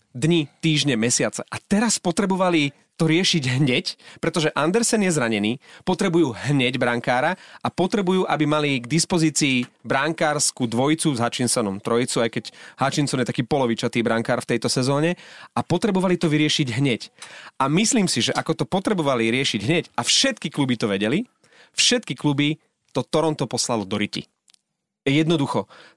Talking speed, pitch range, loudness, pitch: 150 wpm, 125-170 Hz, -21 LUFS, 150 Hz